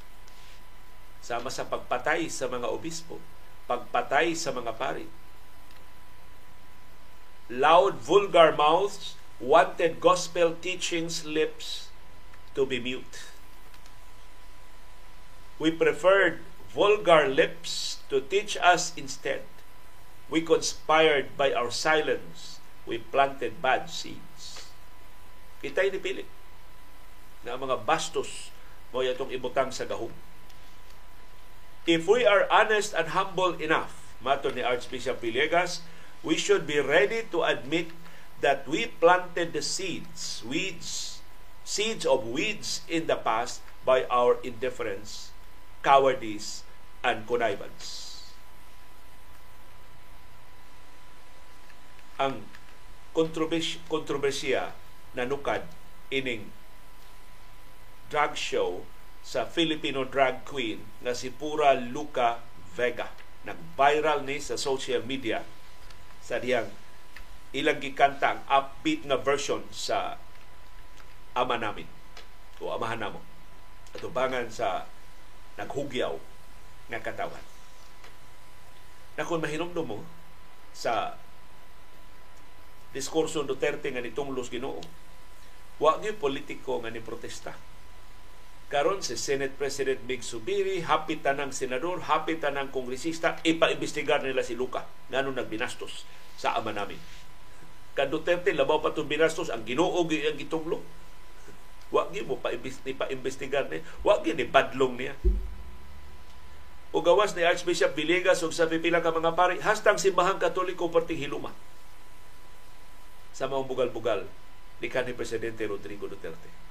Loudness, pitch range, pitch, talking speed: -28 LUFS, 110-175 Hz, 145 Hz, 105 wpm